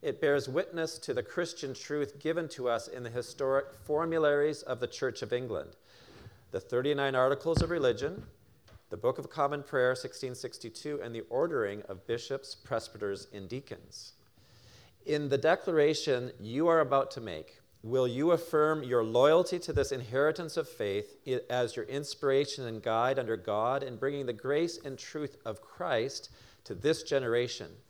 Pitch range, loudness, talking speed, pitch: 120-155 Hz, -32 LUFS, 160 wpm, 135 Hz